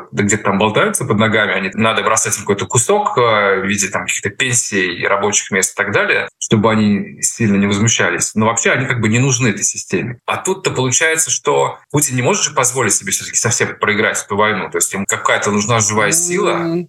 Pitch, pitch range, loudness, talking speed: 115 Hz, 105-135 Hz, -14 LUFS, 205 wpm